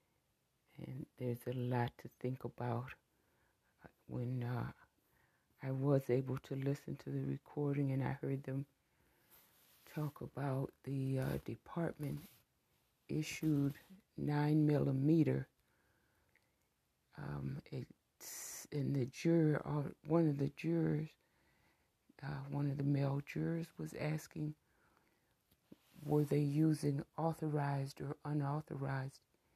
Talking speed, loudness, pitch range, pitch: 105 wpm, -39 LUFS, 135-150 Hz, 140 Hz